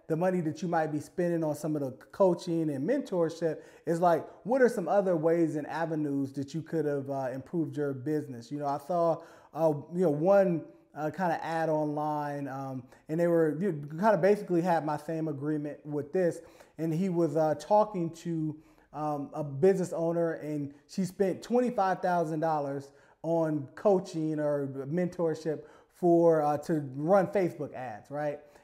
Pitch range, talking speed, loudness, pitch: 150-175 Hz, 180 wpm, -30 LUFS, 160 Hz